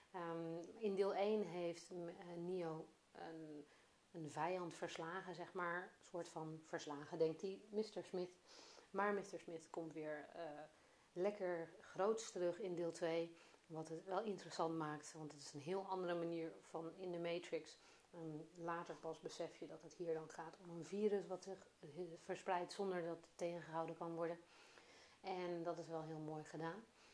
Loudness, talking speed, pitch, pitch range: -48 LUFS, 170 wpm, 170 Hz, 165-185 Hz